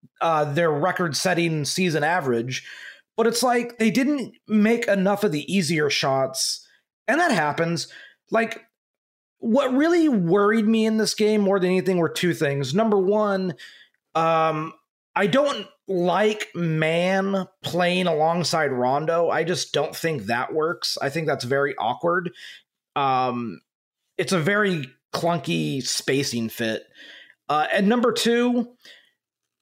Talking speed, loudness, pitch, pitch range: 130 wpm, -22 LUFS, 180 Hz, 155-215 Hz